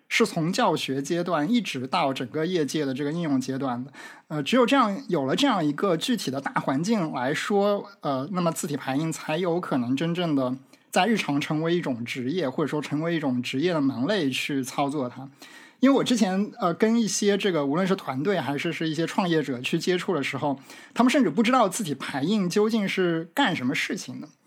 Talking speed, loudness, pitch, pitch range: 315 characters per minute, -25 LUFS, 170 Hz, 140-210 Hz